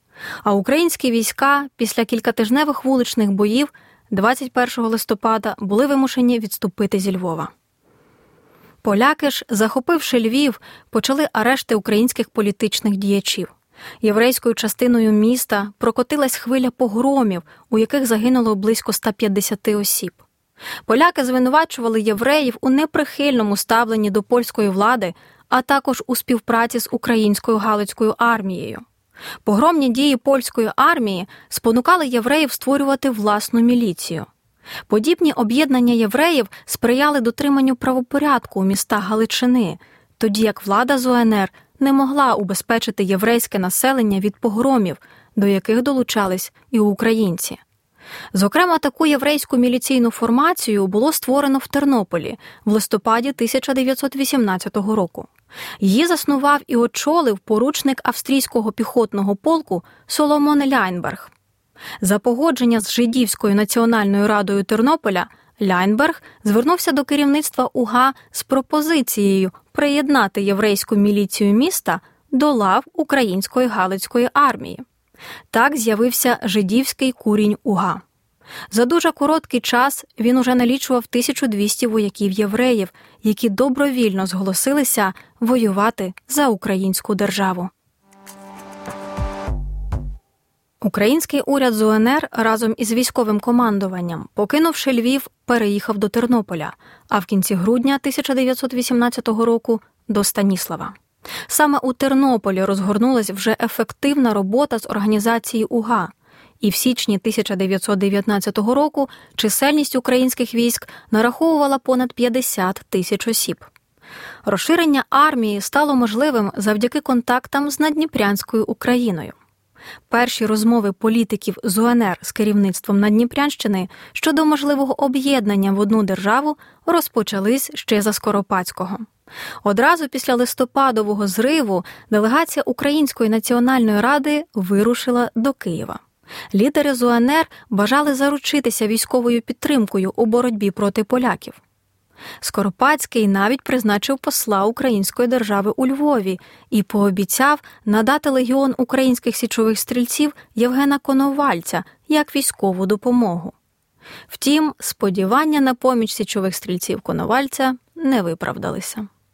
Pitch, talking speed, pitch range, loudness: 235 Hz, 105 wpm, 210-270 Hz, -18 LUFS